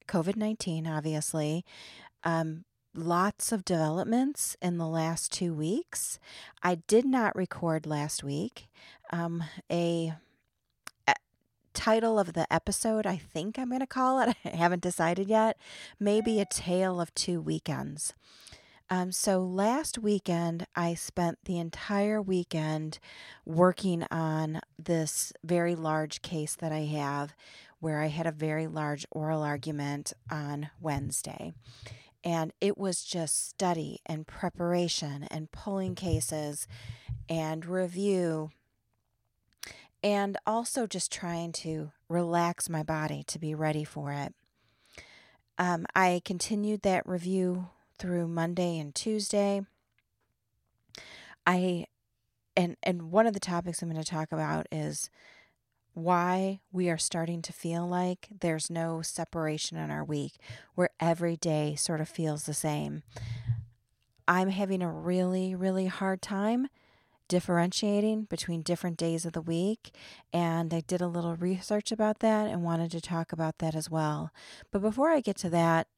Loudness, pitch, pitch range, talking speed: -31 LUFS, 170 Hz, 155-185 Hz, 135 wpm